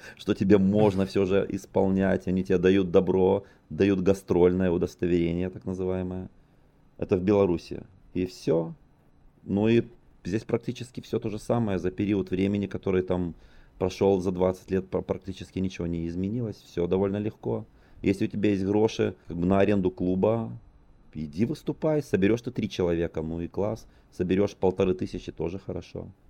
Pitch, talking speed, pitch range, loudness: 95 Hz, 155 wpm, 90-105 Hz, -27 LUFS